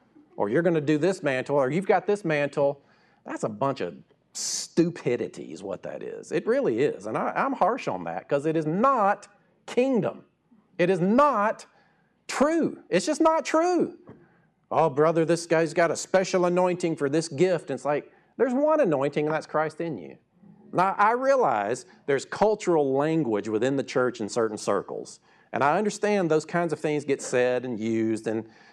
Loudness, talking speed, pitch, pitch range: -25 LUFS, 185 wpm, 170 Hz, 145-210 Hz